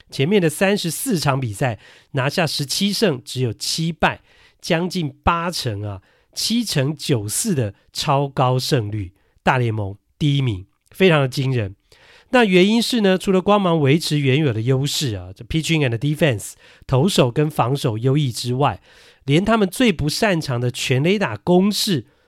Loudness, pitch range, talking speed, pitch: -19 LUFS, 130-180 Hz, 270 characters per minute, 145 Hz